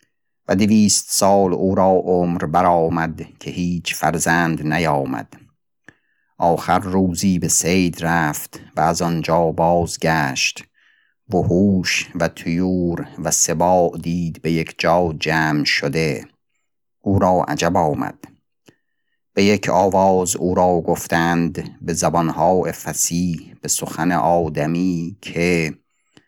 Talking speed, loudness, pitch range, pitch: 110 wpm, -18 LUFS, 85-90 Hz, 85 Hz